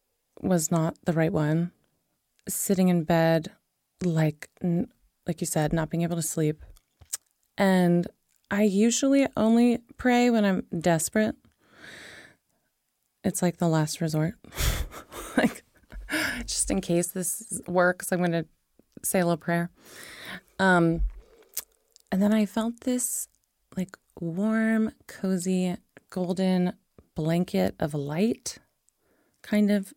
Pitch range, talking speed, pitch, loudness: 170-215 Hz, 115 wpm, 185 Hz, -26 LUFS